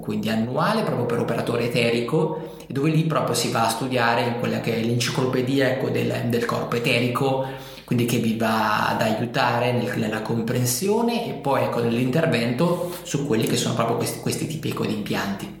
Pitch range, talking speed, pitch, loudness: 115-140 Hz, 170 wpm, 120 Hz, -23 LUFS